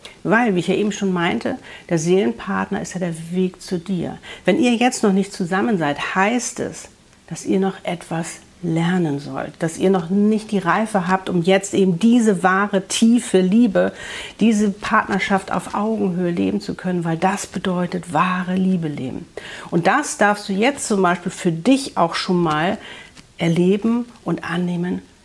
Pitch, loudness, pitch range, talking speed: 190 Hz, -19 LUFS, 175-210 Hz, 170 wpm